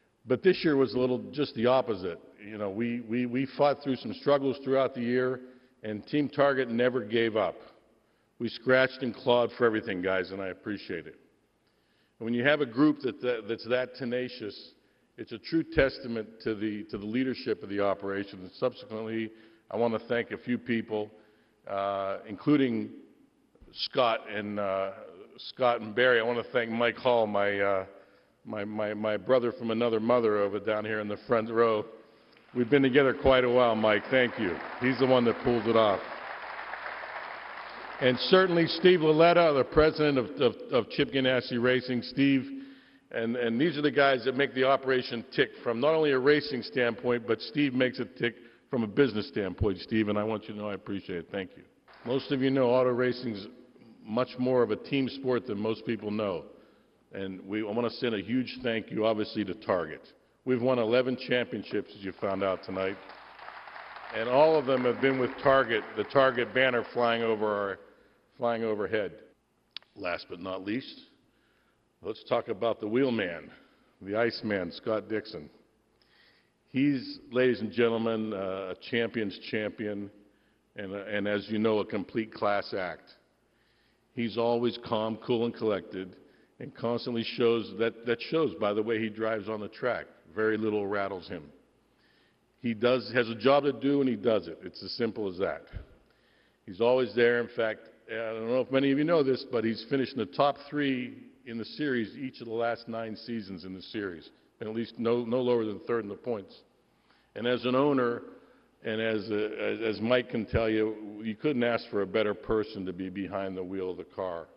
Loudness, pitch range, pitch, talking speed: -29 LUFS, 105-130 Hz, 115 Hz, 190 wpm